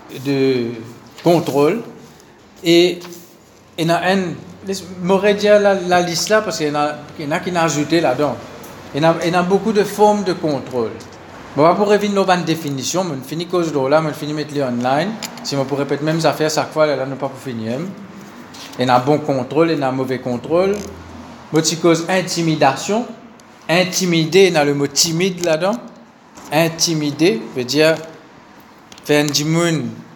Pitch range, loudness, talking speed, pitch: 140-180 Hz, -17 LUFS, 200 wpm, 160 Hz